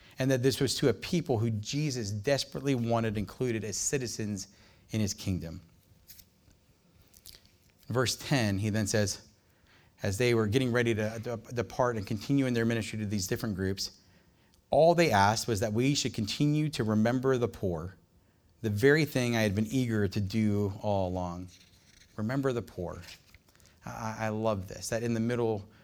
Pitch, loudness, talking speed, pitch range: 110 Hz, -30 LUFS, 165 wpm, 95-120 Hz